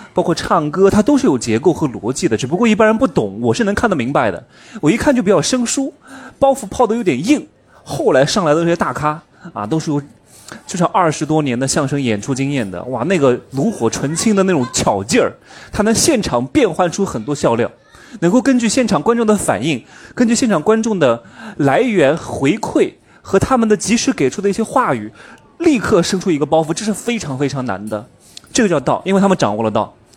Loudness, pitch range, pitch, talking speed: -15 LUFS, 140-235 Hz, 190 Hz, 315 characters per minute